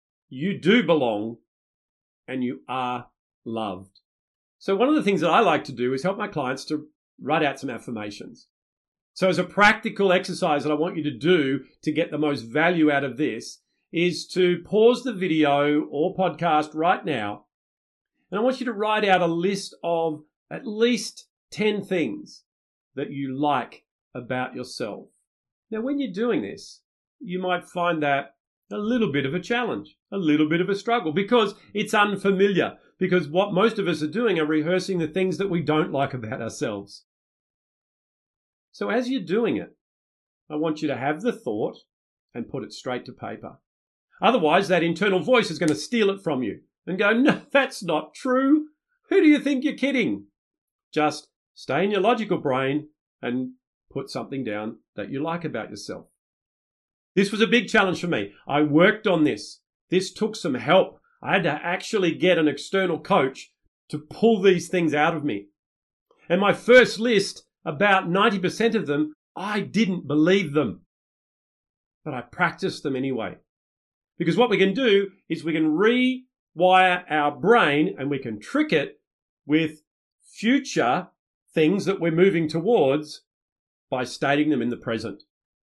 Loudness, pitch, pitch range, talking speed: -23 LUFS, 175 Hz, 145-205 Hz, 170 wpm